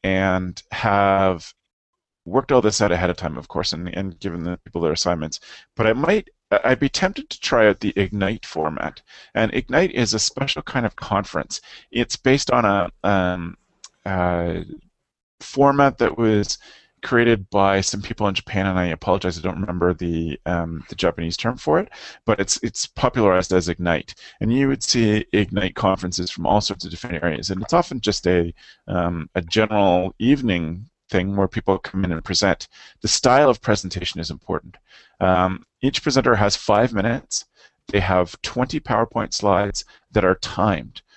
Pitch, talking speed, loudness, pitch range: 95 Hz, 175 wpm, -21 LUFS, 90-115 Hz